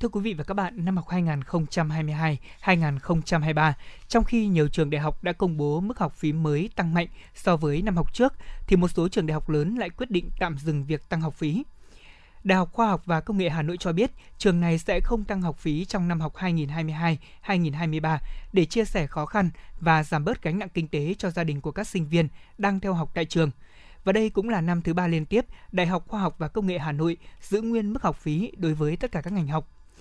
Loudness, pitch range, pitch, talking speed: -26 LUFS, 155-195 Hz, 170 Hz, 240 wpm